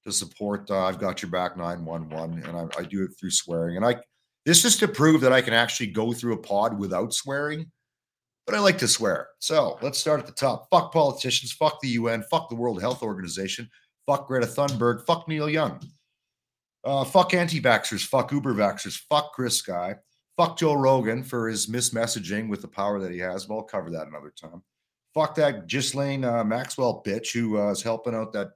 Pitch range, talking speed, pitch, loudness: 100-140 Hz, 210 wpm, 120 Hz, -25 LUFS